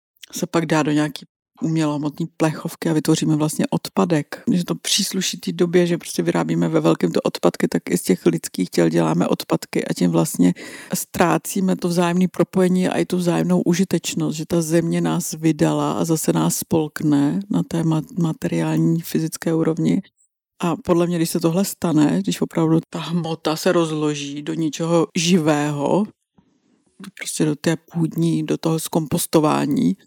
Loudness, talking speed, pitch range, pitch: -20 LUFS, 160 wpm, 155-180 Hz, 165 Hz